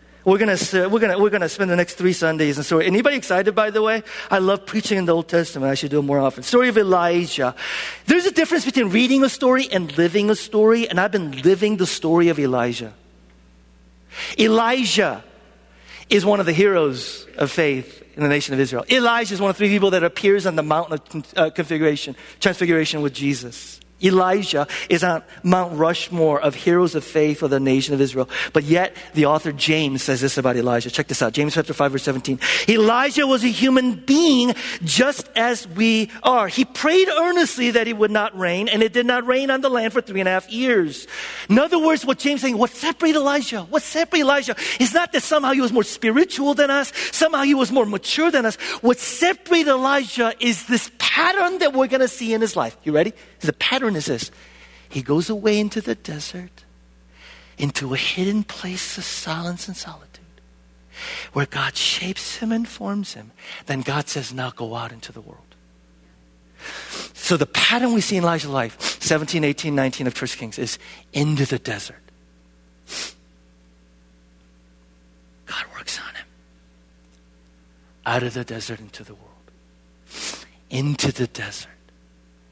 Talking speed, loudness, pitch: 185 wpm, -19 LUFS, 175 Hz